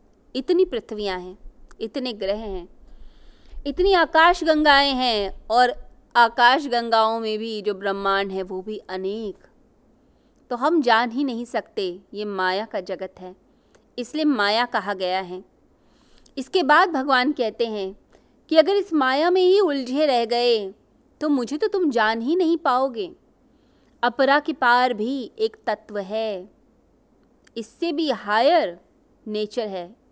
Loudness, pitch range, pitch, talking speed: -21 LUFS, 205-285 Hz, 240 Hz, 140 wpm